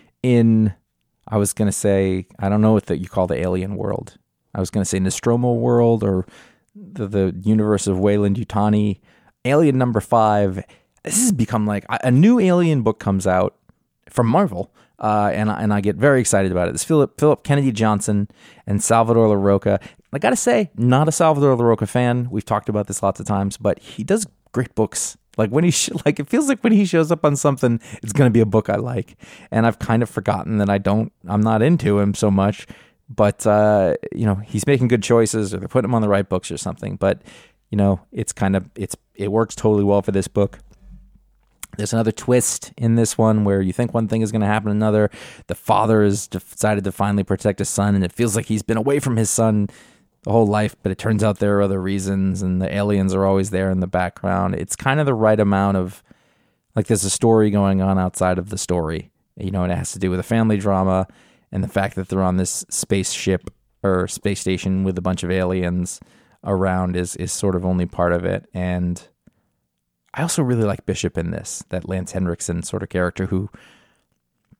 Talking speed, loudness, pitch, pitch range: 220 wpm, -19 LUFS, 105 Hz, 95-115 Hz